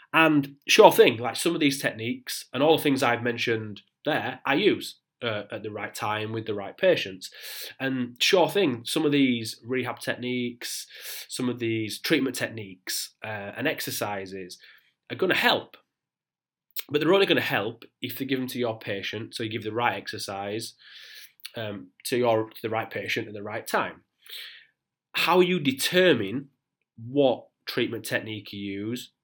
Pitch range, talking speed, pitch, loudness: 110-135 Hz, 170 wpm, 120 Hz, -26 LUFS